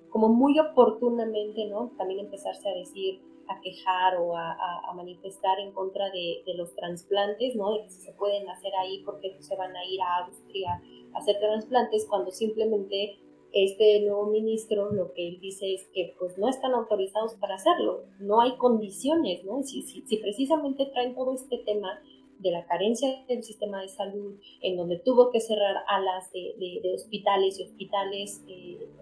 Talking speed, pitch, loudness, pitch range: 180 wpm, 205 Hz, -28 LUFS, 190-240 Hz